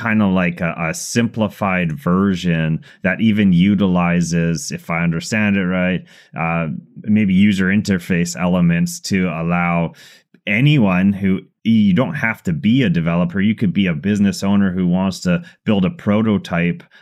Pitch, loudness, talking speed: 100 Hz, -17 LUFS, 150 wpm